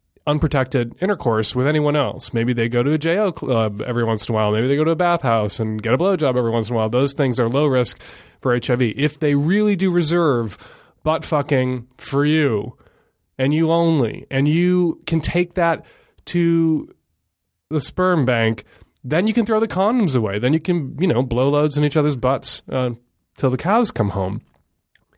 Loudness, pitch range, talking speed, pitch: -19 LUFS, 120-165 Hz, 205 wpm, 140 Hz